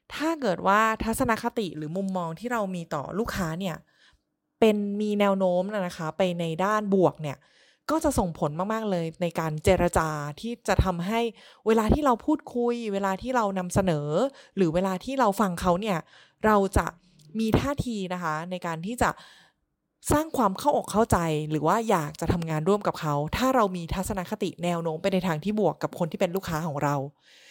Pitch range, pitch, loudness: 170-220 Hz, 190 Hz, -26 LUFS